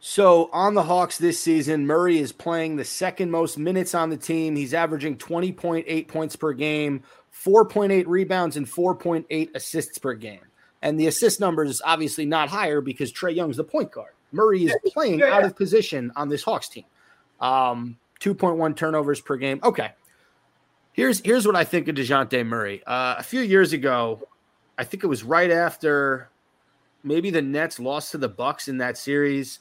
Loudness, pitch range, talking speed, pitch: -23 LUFS, 140-180 Hz, 195 wpm, 160 Hz